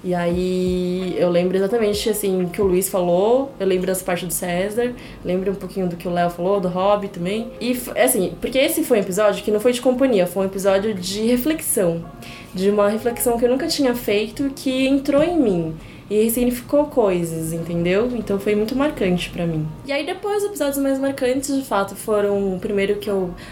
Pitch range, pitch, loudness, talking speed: 185-250 Hz, 205 Hz, -20 LUFS, 205 wpm